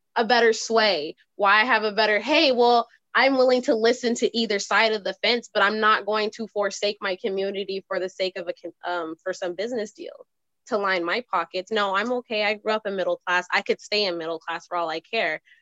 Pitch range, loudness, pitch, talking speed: 190-230 Hz, -23 LUFS, 210 Hz, 235 wpm